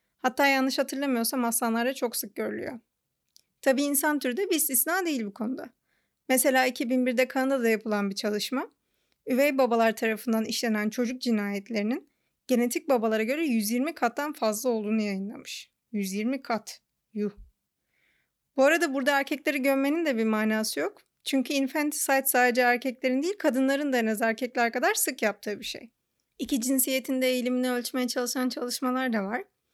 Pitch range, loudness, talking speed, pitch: 230-275 Hz, -27 LUFS, 145 wpm, 255 Hz